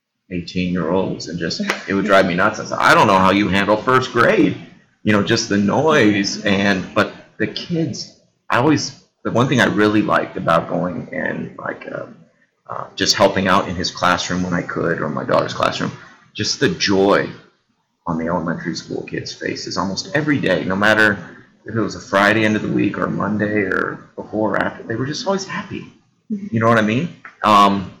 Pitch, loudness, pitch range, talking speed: 100 Hz, -18 LUFS, 95-110 Hz, 205 wpm